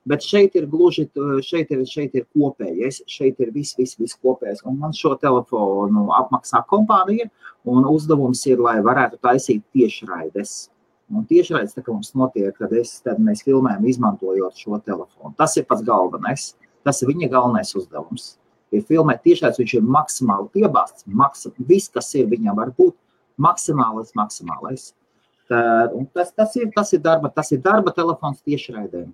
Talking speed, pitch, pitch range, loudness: 145 wpm, 140 Hz, 125-175 Hz, -19 LUFS